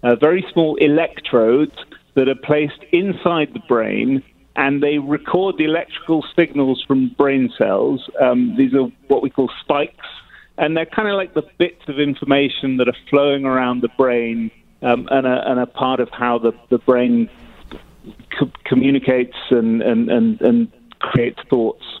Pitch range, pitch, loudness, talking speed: 125-170 Hz, 140 Hz, -18 LUFS, 160 wpm